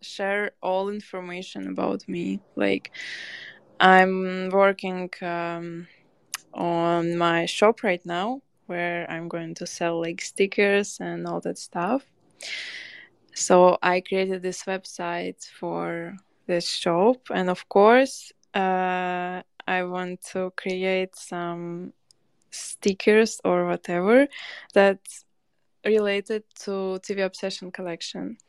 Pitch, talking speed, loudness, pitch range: 185 Hz, 105 wpm, -24 LUFS, 175-195 Hz